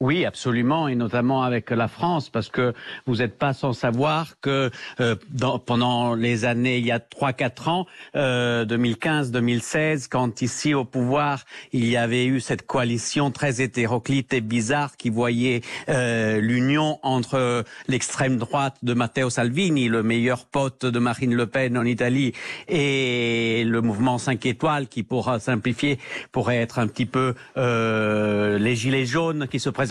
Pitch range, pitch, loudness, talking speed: 120-135 Hz, 125 Hz, -23 LUFS, 160 wpm